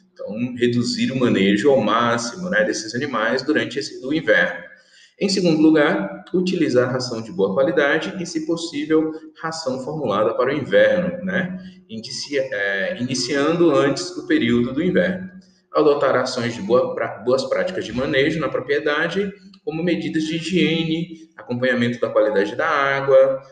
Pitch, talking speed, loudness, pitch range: 160 Hz, 145 wpm, -20 LUFS, 130-185 Hz